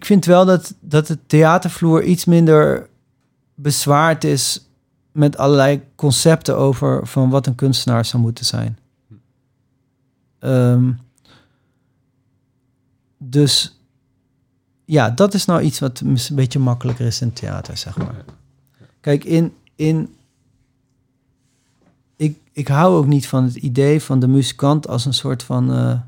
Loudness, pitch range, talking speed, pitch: -16 LUFS, 130-145 Hz, 130 wpm, 135 Hz